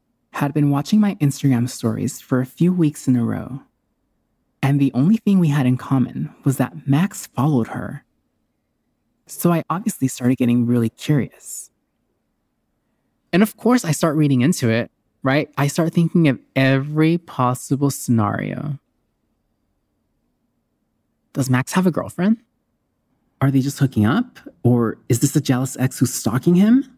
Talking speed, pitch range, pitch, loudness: 150 wpm, 125-165 Hz, 140 Hz, -19 LUFS